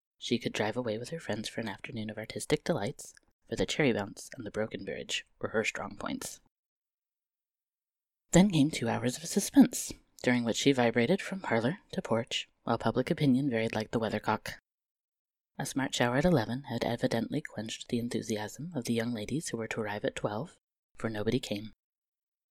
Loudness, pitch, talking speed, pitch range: -32 LUFS, 120 Hz, 185 wpm, 110-140 Hz